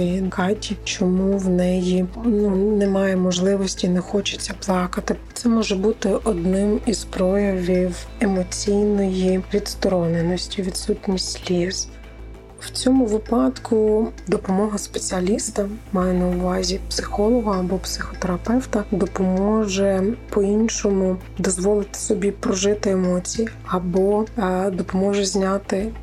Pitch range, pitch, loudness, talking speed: 185-210 Hz, 195 Hz, -21 LUFS, 95 wpm